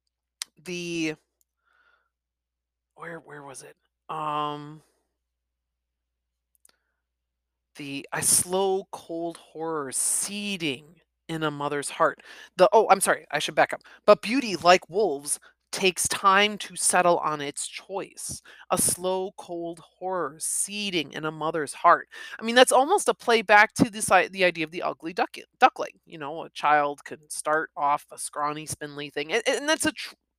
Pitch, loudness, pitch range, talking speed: 160 Hz, -24 LUFS, 145-190 Hz, 150 wpm